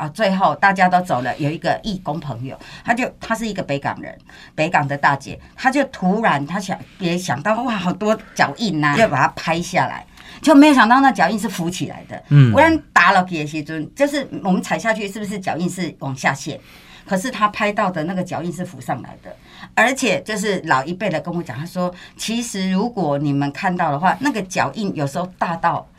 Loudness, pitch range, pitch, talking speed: -18 LUFS, 155-215 Hz, 185 Hz, 310 characters per minute